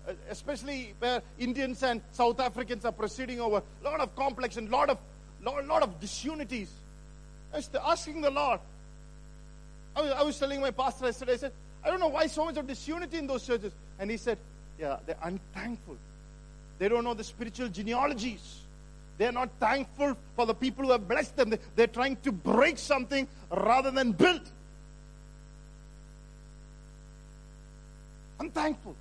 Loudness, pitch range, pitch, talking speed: -31 LUFS, 225-280 Hz, 255 Hz, 155 wpm